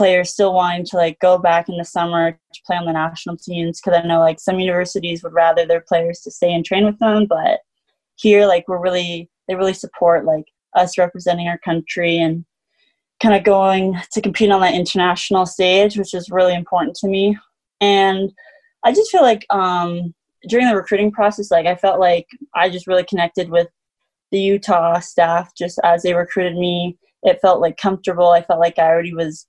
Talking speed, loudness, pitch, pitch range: 200 wpm, -16 LUFS, 180 Hz, 170-195 Hz